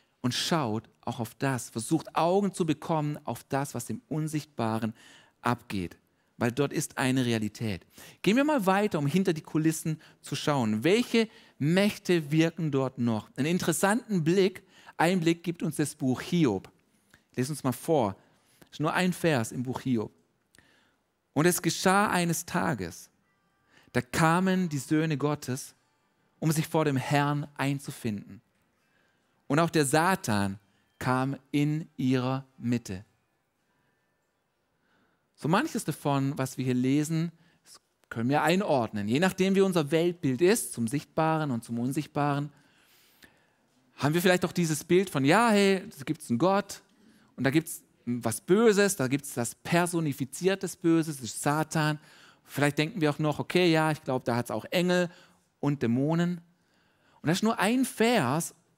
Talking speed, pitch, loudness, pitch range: 155 wpm, 150 Hz, -28 LUFS, 130-175 Hz